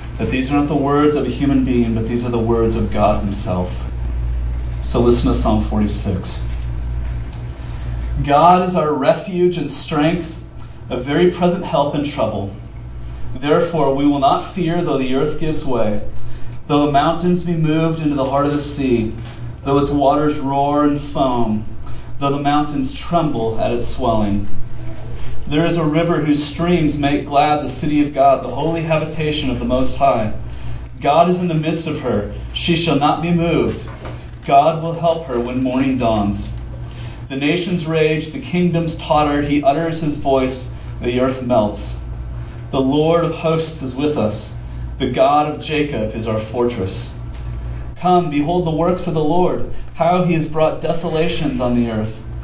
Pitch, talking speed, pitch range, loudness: 140 Hz, 170 wpm, 115-155 Hz, -18 LUFS